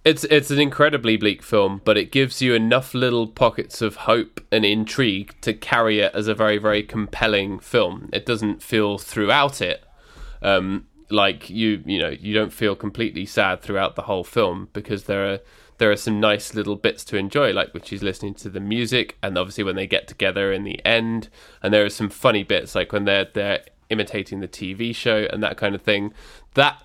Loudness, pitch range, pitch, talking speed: -21 LUFS, 100-115 Hz, 105 Hz, 205 wpm